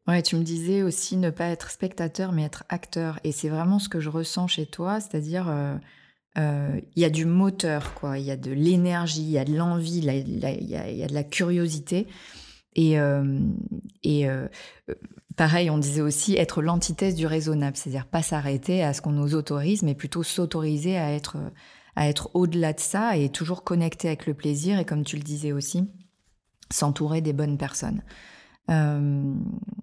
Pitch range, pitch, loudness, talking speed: 150-180 Hz, 160 Hz, -26 LUFS, 190 wpm